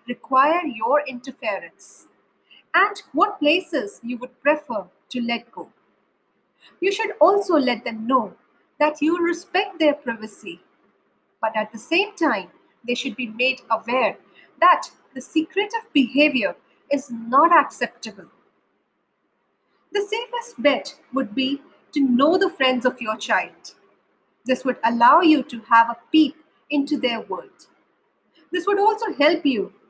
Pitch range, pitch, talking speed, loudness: 250-335 Hz, 285 Hz, 140 wpm, -21 LUFS